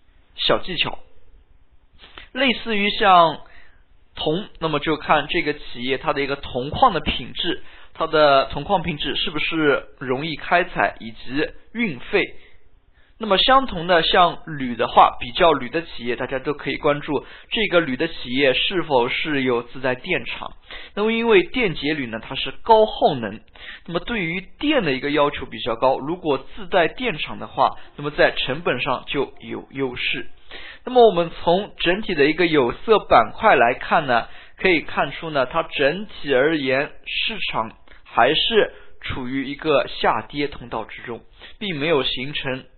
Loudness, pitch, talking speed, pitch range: -20 LUFS, 155 Hz, 235 characters per minute, 135-190 Hz